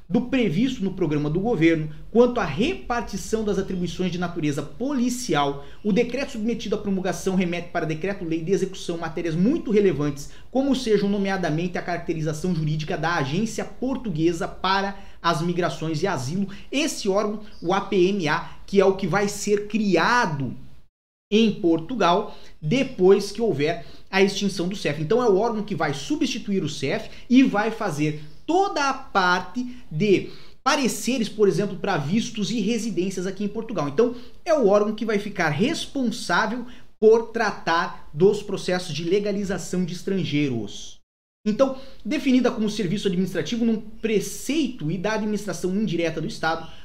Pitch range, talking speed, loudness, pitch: 175-225 Hz, 150 wpm, -24 LUFS, 195 Hz